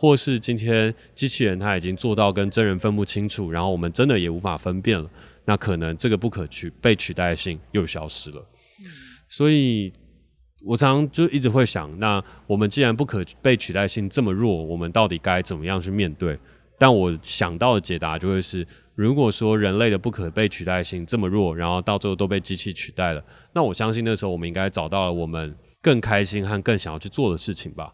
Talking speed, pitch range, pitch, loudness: 320 characters per minute, 90-115 Hz, 100 Hz, -22 LUFS